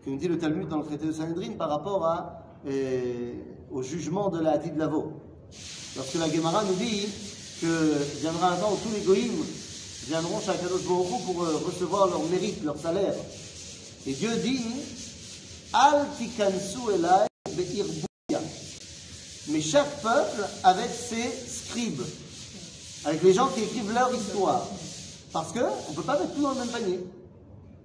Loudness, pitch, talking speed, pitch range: -28 LUFS, 185 Hz, 150 wpm, 155-225 Hz